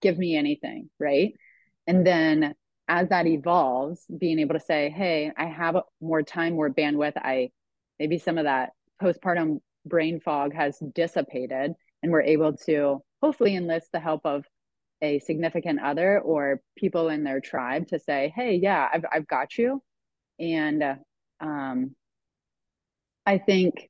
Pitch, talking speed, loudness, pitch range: 160 Hz, 150 wpm, -26 LUFS, 145-175 Hz